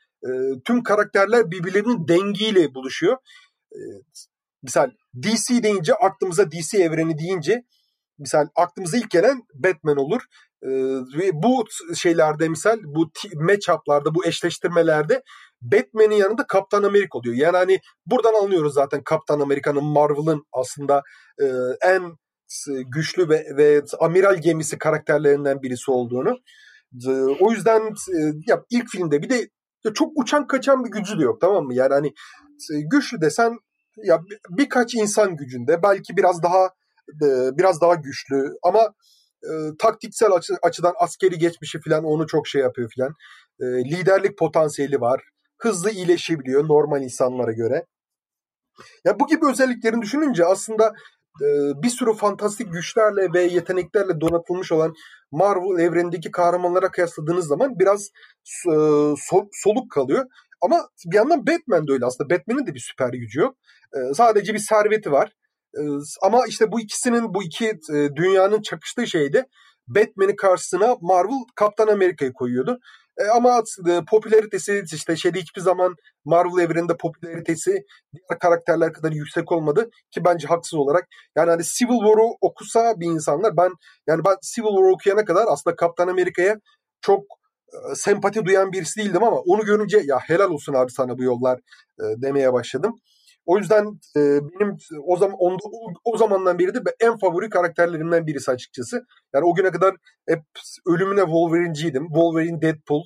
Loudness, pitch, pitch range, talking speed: -20 LUFS, 185 Hz, 155-220 Hz, 140 wpm